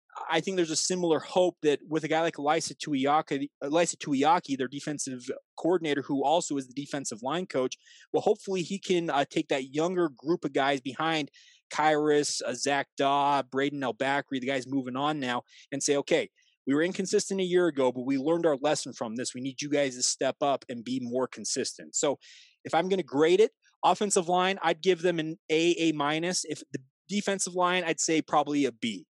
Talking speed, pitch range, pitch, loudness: 205 wpm, 140-180 Hz, 155 Hz, -28 LUFS